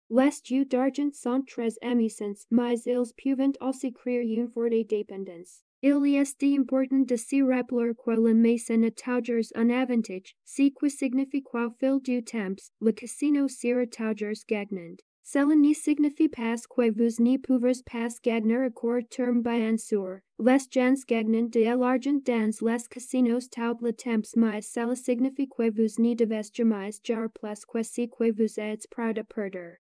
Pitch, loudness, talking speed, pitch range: 235 Hz, -27 LUFS, 150 wpm, 225-260 Hz